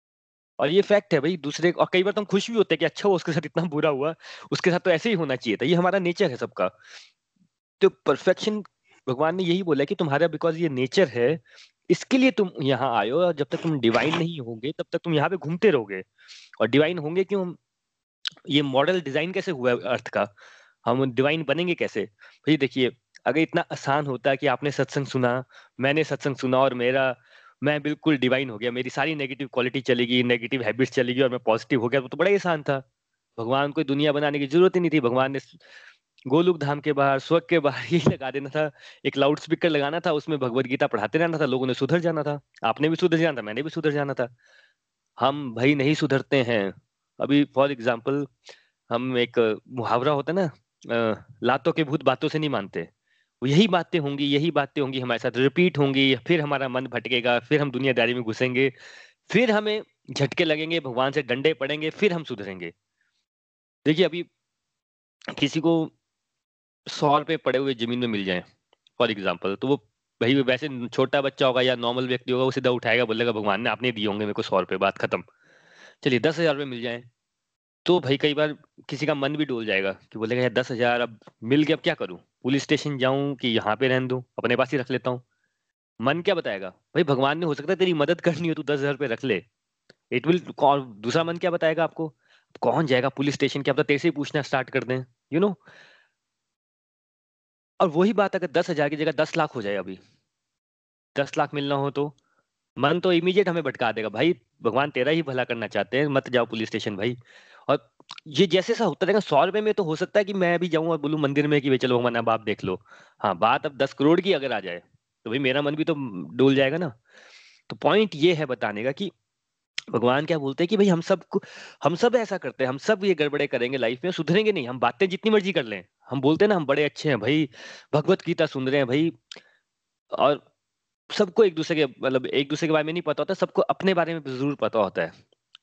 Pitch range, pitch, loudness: 125-165 Hz, 145 Hz, -24 LUFS